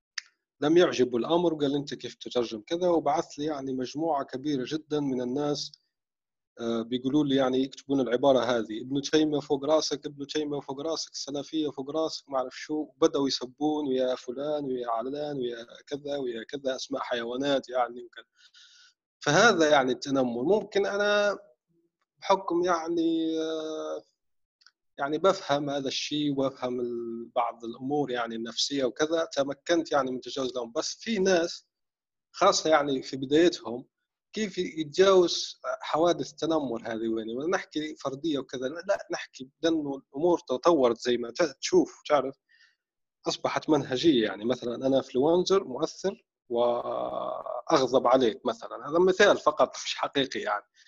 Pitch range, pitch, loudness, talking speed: 125-165 Hz, 145 Hz, -28 LUFS, 130 wpm